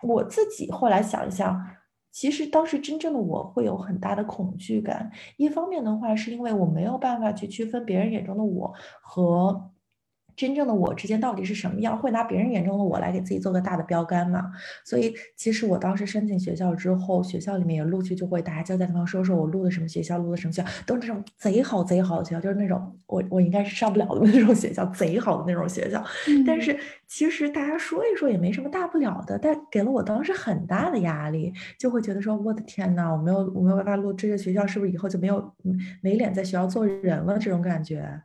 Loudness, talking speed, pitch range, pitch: -25 LUFS, 355 characters per minute, 185-230 Hz, 200 Hz